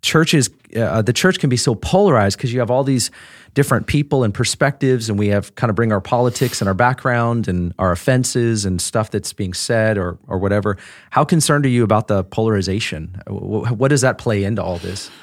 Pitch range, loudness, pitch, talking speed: 100-130 Hz, -17 LUFS, 115 Hz, 210 wpm